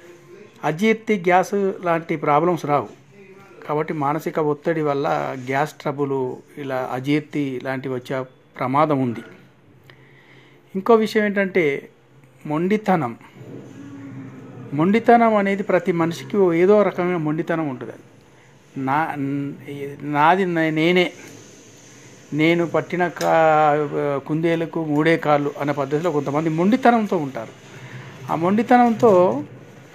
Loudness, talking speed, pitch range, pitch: -20 LUFS, 90 wpm, 140-180 Hz, 155 Hz